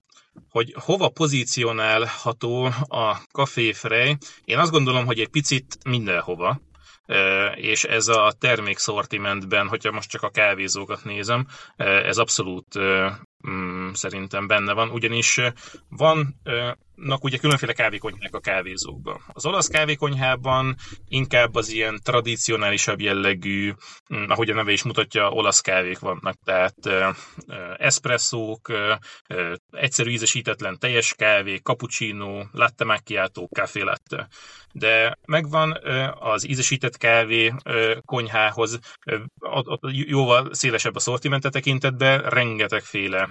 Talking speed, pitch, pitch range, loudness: 100 wpm, 115 Hz, 105-135 Hz, -22 LUFS